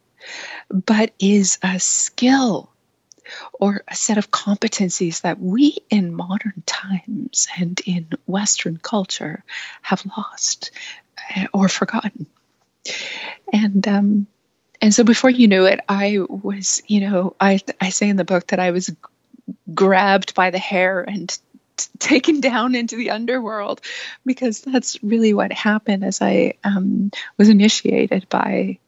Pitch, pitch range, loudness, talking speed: 205 Hz, 190-230 Hz, -18 LUFS, 135 wpm